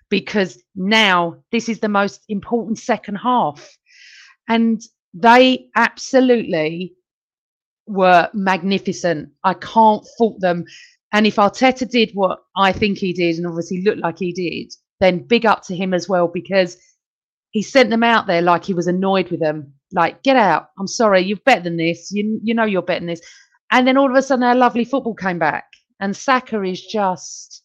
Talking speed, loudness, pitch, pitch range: 180 wpm, -17 LUFS, 195 Hz, 180-230 Hz